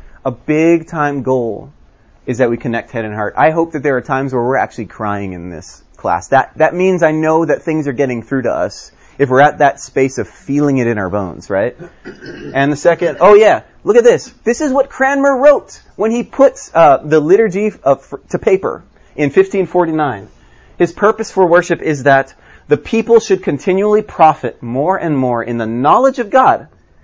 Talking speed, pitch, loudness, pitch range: 200 wpm, 150 Hz, -13 LUFS, 125-200 Hz